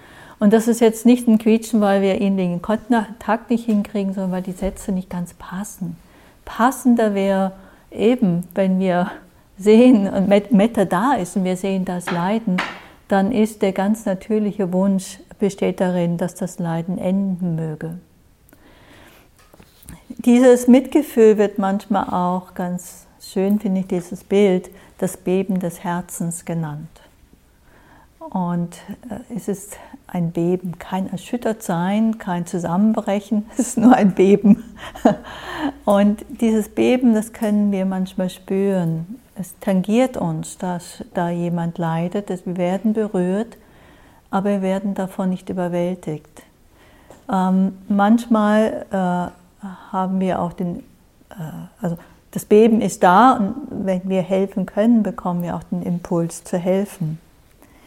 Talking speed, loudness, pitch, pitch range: 130 wpm, -19 LUFS, 195 Hz, 180-215 Hz